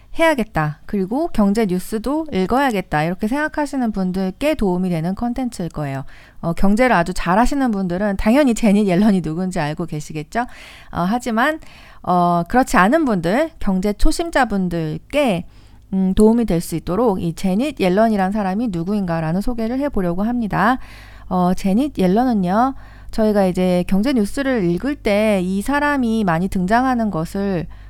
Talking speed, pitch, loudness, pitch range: 340 characters per minute, 205 Hz, -18 LUFS, 180-245 Hz